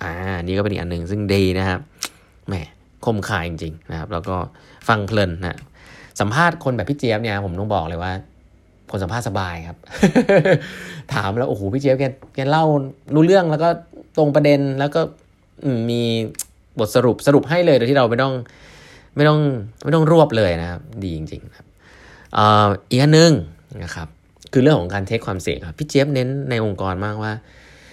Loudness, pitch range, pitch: -19 LUFS, 95-140 Hz, 110 Hz